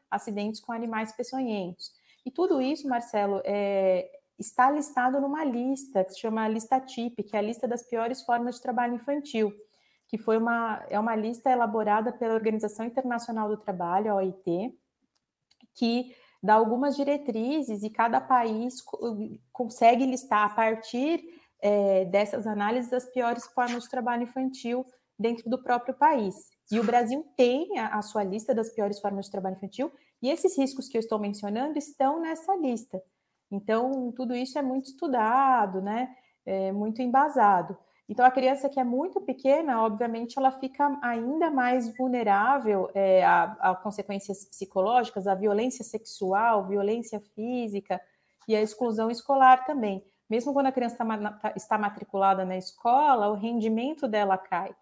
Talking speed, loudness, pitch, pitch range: 155 wpm, -27 LUFS, 235 Hz, 210-260 Hz